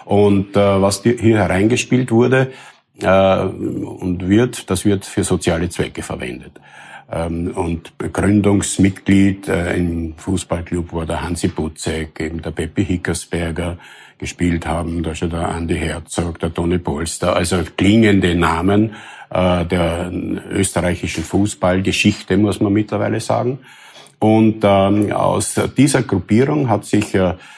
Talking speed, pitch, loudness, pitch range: 125 wpm, 95 Hz, -17 LUFS, 85-105 Hz